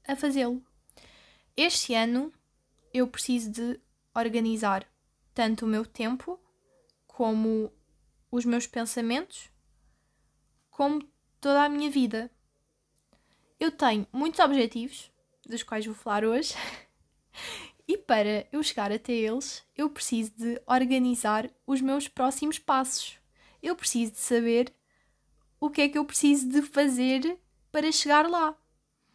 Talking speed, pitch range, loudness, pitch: 120 wpm, 230-290 Hz, -28 LUFS, 255 Hz